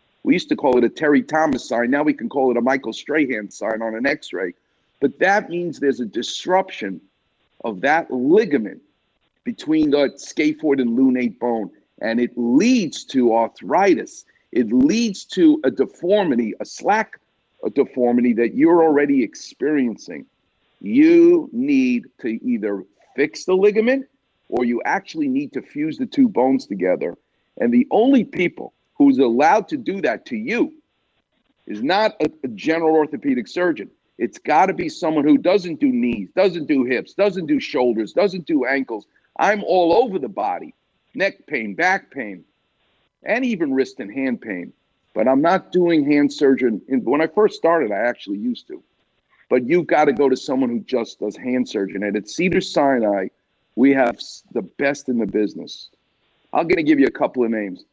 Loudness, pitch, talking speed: -19 LUFS, 175 Hz, 175 wpm